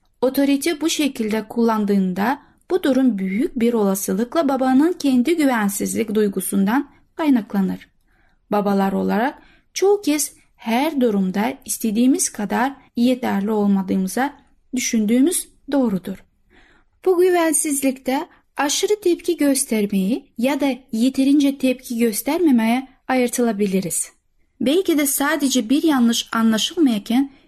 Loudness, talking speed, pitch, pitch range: -19 LUFS, 95 wpm, 255 Hz, 220-285 Hz